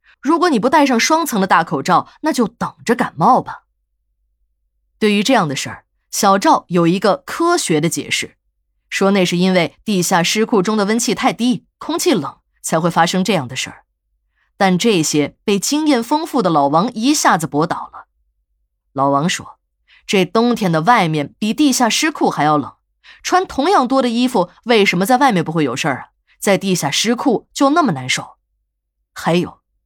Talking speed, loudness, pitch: 255 characters per minute, -16 LUFS, 195 Hz